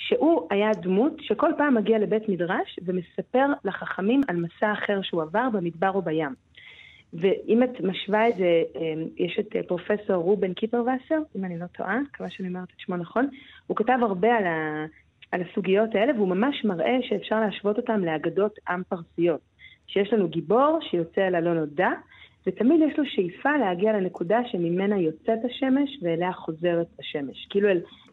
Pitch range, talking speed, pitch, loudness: 175-230 Hz, 160 wpm, 200 Hz, -25 LUFS